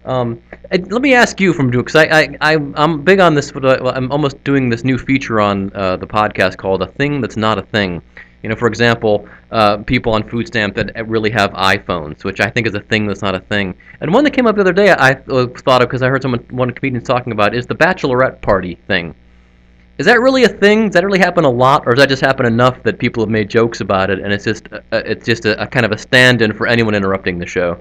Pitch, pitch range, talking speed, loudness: 120 Hz, 105-140 Hz, 260 wpm, -14 LUFS